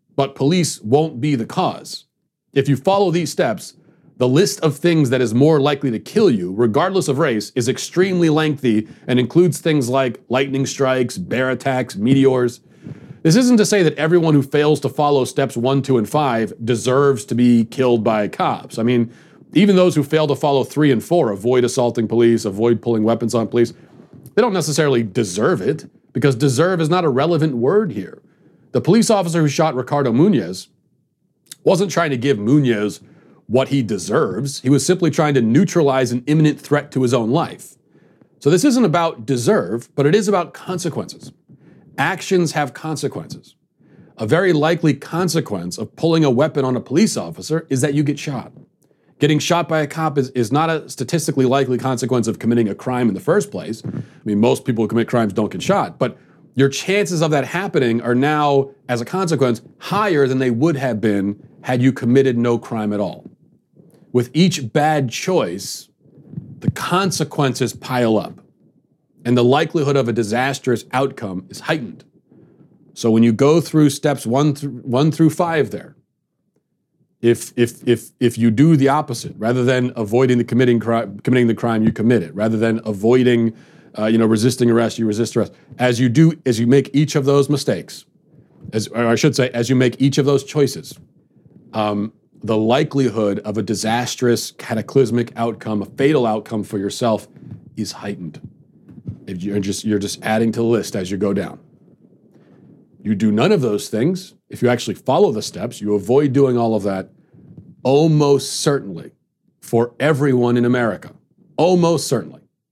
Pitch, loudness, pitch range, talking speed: 130 Hz, -17 LUFS, 115-150 Hz, 180 wpm